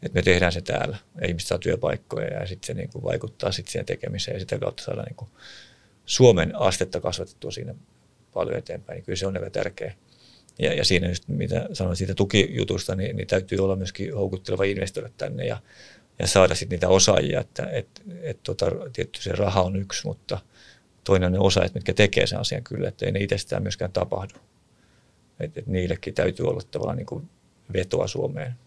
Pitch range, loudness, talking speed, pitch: 90-100 Hz, -25 LUFS, 185 wpm, 95 Hz